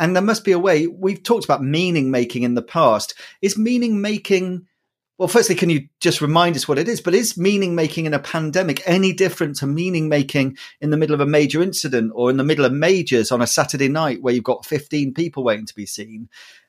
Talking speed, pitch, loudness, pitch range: 235 wpm, 155 Hz, -19 LUFS, 135-185 Hz